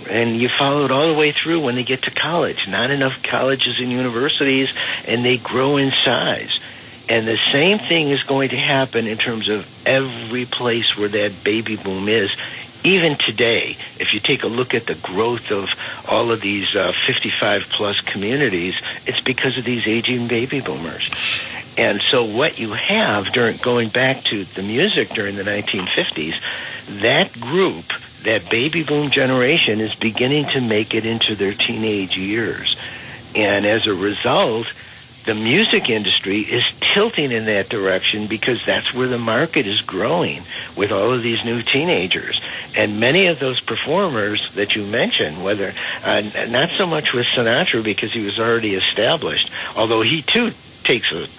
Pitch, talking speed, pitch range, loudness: 120 Hz, 170 wpm, 110-135 Hz, -18 LUFS